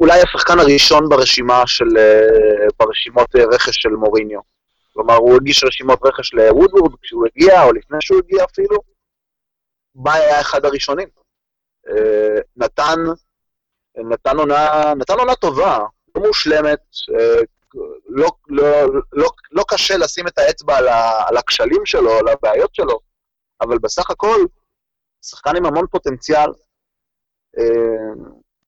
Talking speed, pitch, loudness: 120 wpm, 165 Hz, -14 LUFS